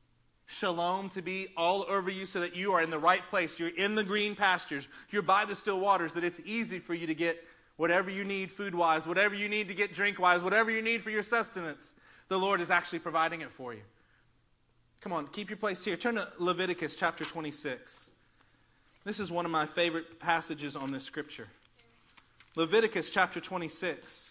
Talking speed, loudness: 200 wpm, -31 LUFS